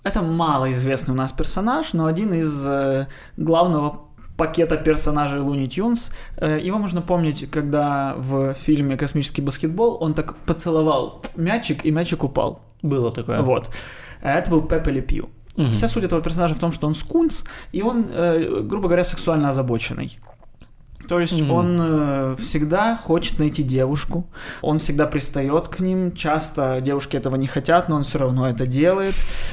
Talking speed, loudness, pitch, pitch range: 150 wpm, -21 LUFS, 155 Hz, 140-170 Hz